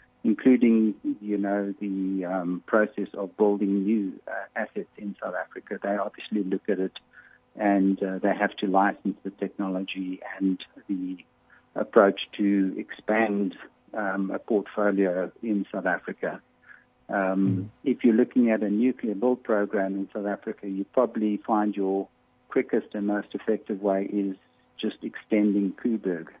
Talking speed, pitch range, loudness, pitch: 145 wpm, 95-105 Hz, -27 LUFS, 100 Hz